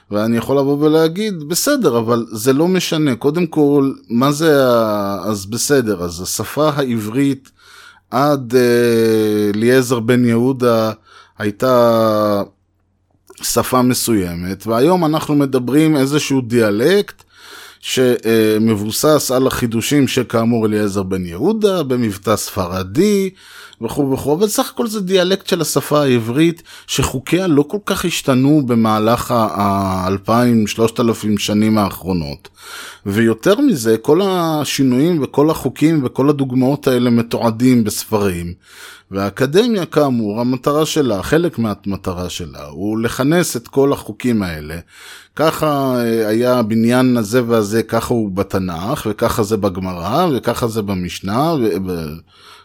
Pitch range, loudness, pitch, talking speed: 105-145 Hz, -16 LUFS, 120 Hz, 115 wpm